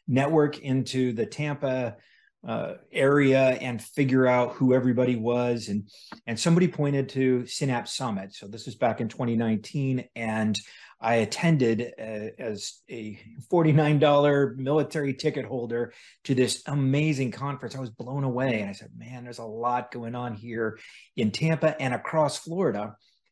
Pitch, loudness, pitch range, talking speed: 125 Hz, -26 LUFS, 115-140 Hz, 150 wpm